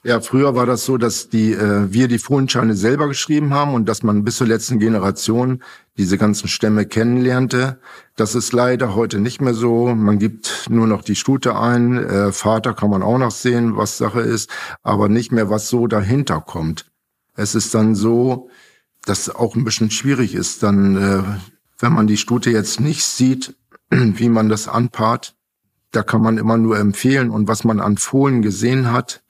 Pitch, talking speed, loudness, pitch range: 115 Hz, 190 wpm, -17 LUFS, 105-125 Hz